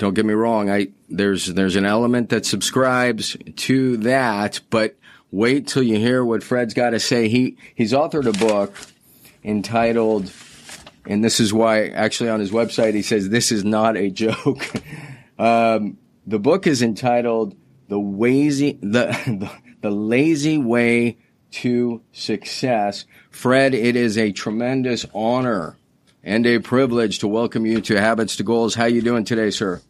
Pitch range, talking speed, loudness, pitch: 110-120 Hz, 160 wpm, -19 LUFS, 115 Hz